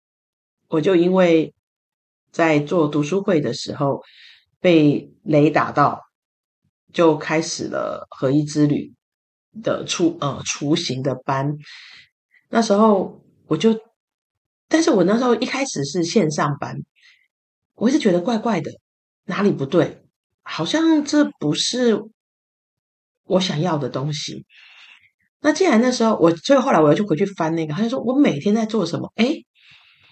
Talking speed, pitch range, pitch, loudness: 200 characters per minute, 155-235 Hz, 180 Hz, -19 LUFS